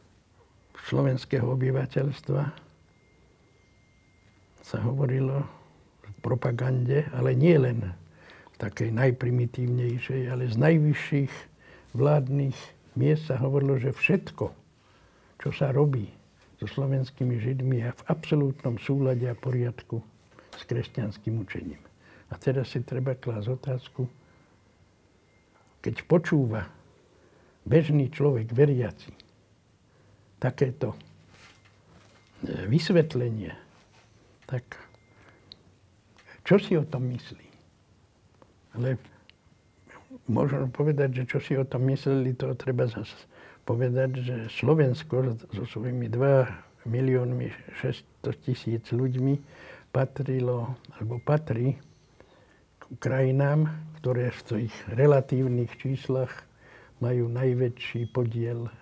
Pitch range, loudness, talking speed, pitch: 110-135 Hz, -27 LUFS, 90 wpm, 125 Hz